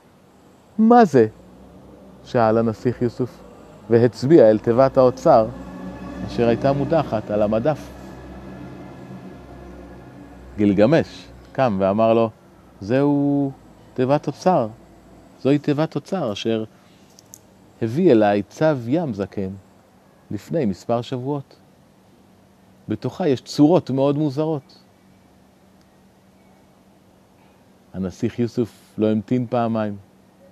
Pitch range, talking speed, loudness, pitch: 100-135 Hz, 85 wpm, -20 LUFS, 115 Hz